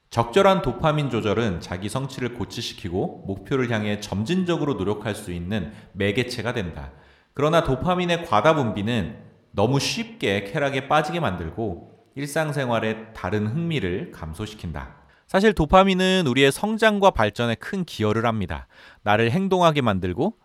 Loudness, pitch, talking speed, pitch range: -23 LUFS, 115 Hz, 330 characters per minute, 105-160 Hz